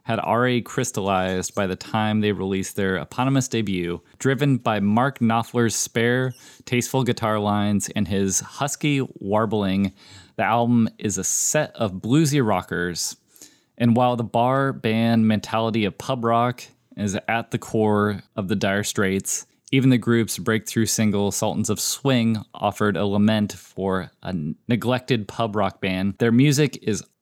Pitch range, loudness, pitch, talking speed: 100-120 Hz, -22 LUFS, 110 Hz, 150 wpm